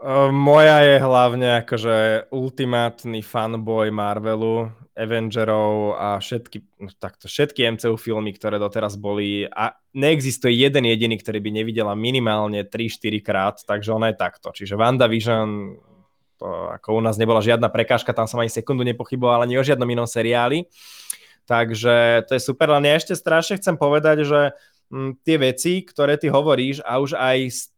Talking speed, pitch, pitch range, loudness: 160 wpm, 120 Hz, 110-135 Hz, -19 LUFS